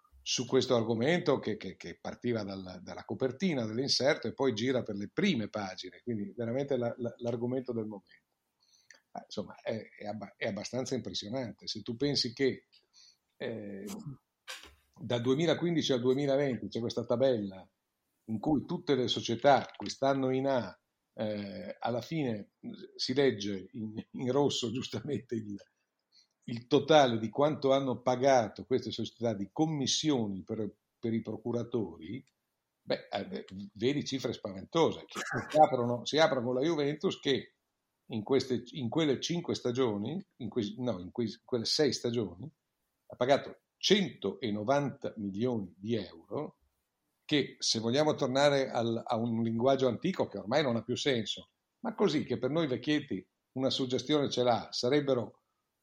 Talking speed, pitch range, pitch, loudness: 145 wpm, 110-135 Hz, 120 Hz, -32 LUFS